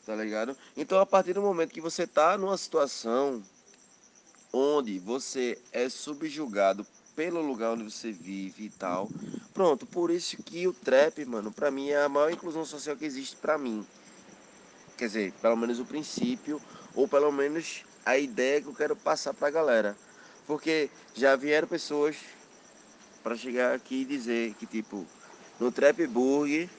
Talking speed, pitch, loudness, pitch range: 160 wpm, 145 Hz, -29 LUFS, 120-165 Hz